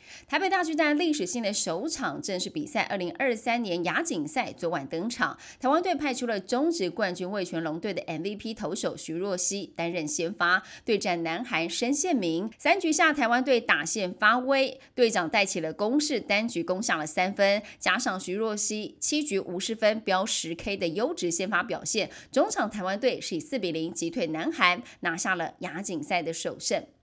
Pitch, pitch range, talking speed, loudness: 205 Hz, 180-255 Hz, 285 characters per minute, -27 LUFS